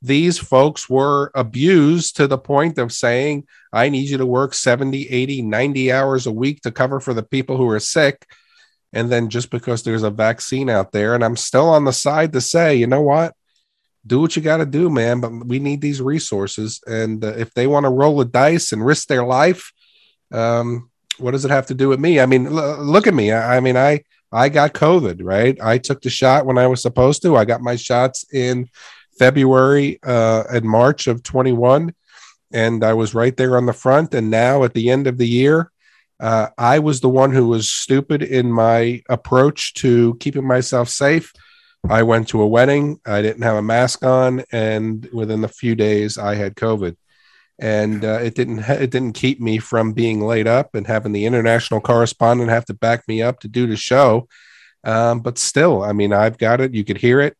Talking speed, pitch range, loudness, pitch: 215 wpm, 115-135 Hz, -16 LUFS, 125 Hz